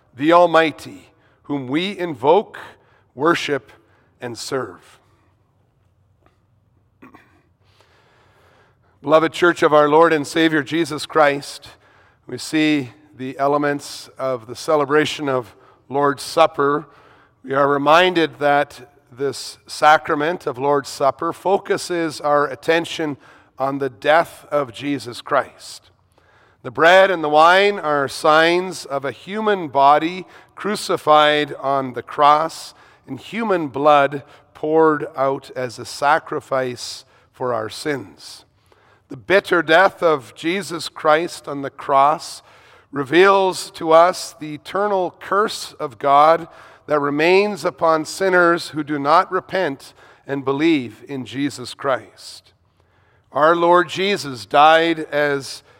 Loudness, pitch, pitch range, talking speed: -18 LUFS, 145 Hz, 130-165 Hz, 115 wpm